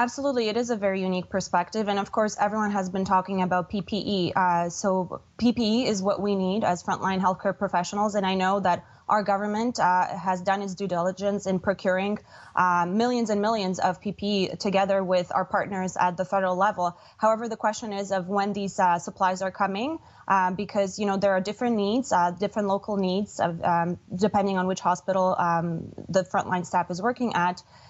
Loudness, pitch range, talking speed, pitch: -26 LUFS, 185-210 Hz, 195 wpm, 195 Hz